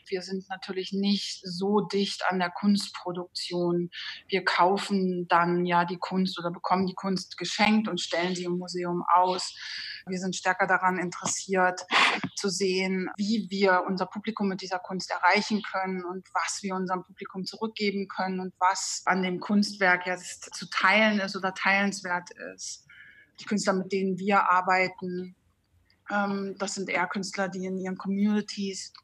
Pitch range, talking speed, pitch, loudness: 180-200 Hz, 155 wpm, 185 Hz, -27 LUFS